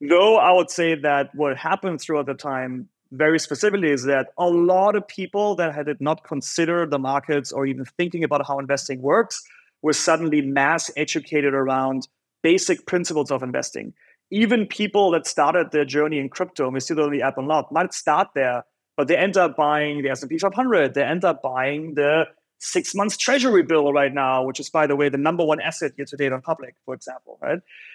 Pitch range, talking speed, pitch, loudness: 140-175 Hz, 200 wpm, 150 Hz, -21 LUFS